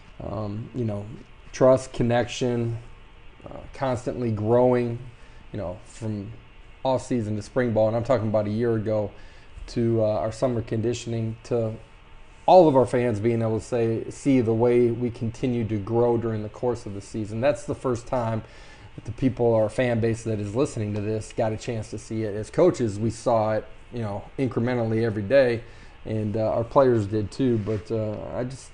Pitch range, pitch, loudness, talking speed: 110-120 Hz, 115 Hz, -25 LUFS, 190 wpm